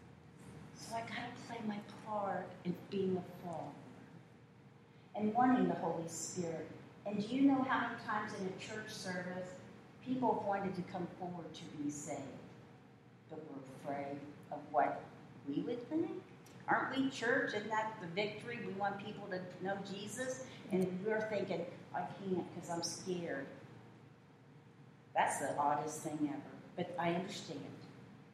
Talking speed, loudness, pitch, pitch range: 155 wpm, -40 LUFS, 180 Hz, 155-215 Hz